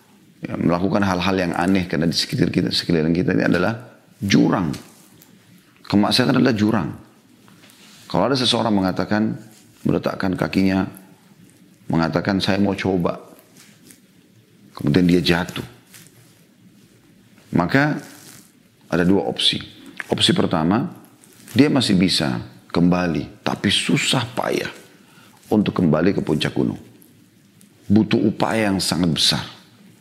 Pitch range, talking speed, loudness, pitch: 85-105 Hz, 105 wpm, -19 LUFS, 95 Hz